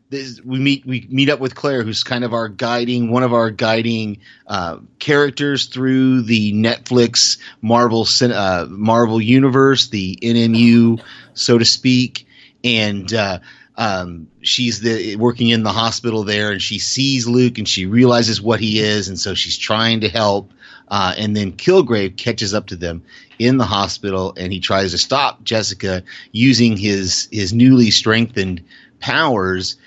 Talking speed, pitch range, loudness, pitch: 160 wpm, 105-125 Hz, -16 LUFS, 115 Hz